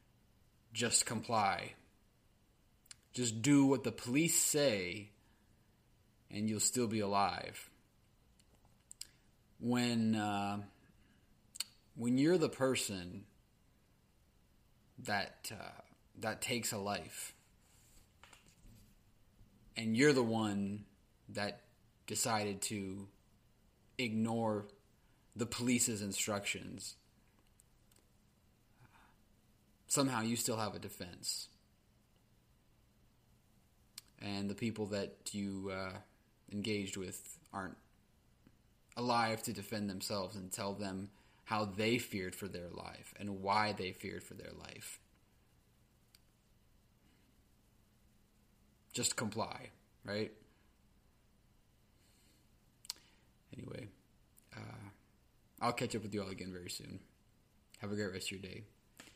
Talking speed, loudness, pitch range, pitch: 95 wpm, -38 LUFS, 100-115 Hz, 105 Hz